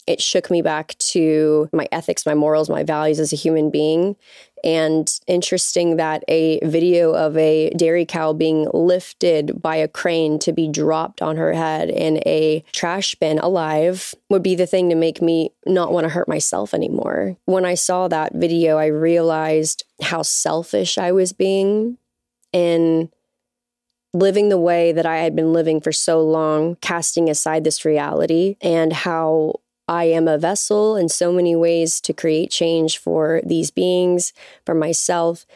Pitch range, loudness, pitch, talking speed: 155-180 Hz, -18 LUFS, 165 Hz, 165 wpm